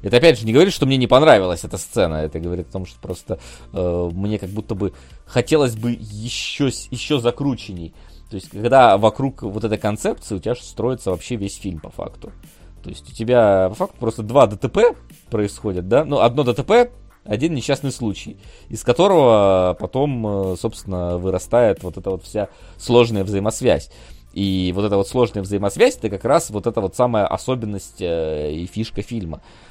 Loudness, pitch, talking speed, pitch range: -19 LUFS, 105 Hz, 180 wpm, 90-120 Hz